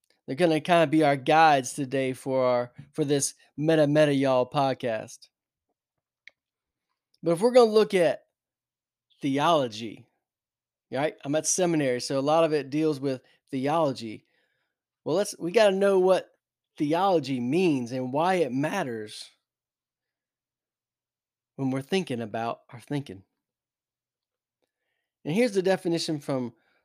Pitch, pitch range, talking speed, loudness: 145 Hz, 130-165 Hz, 130 wpm, -25 LUFS